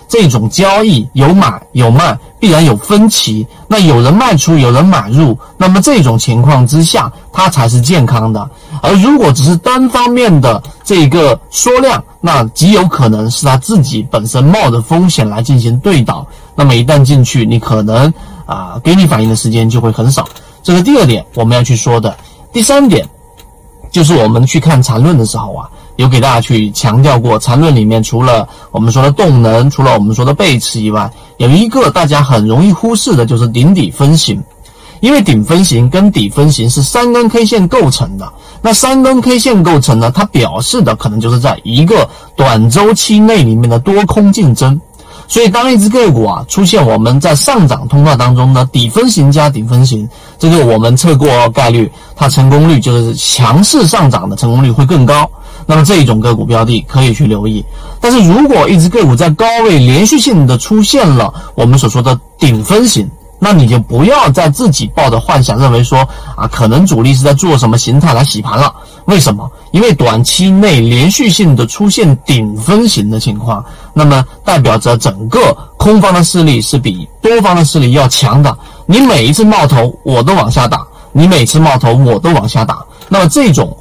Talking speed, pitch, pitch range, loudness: 285 characters per minute, 140 Hz, 120-170 Hz, -8 LUFS